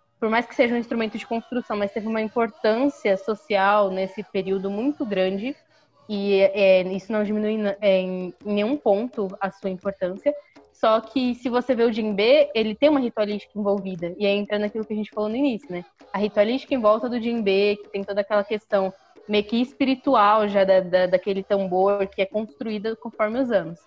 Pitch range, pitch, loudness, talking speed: 195-235 Hz, 210 Hz, -23 LUFS, 195 wpm